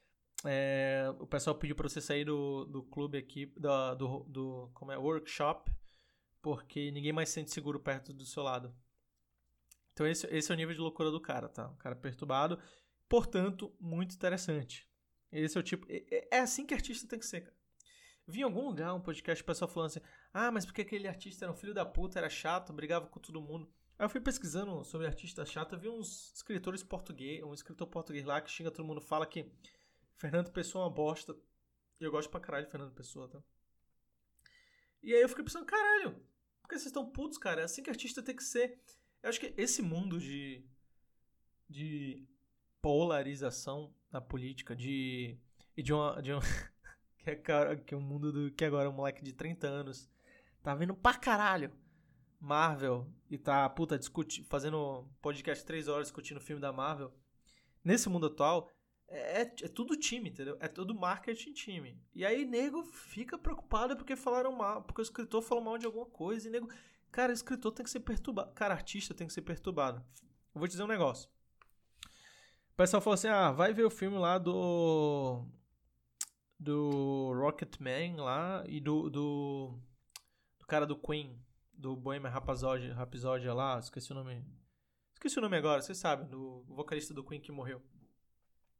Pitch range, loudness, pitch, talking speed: 135-195 Hz, -37 LUFS, 155 Hz, 185 wpm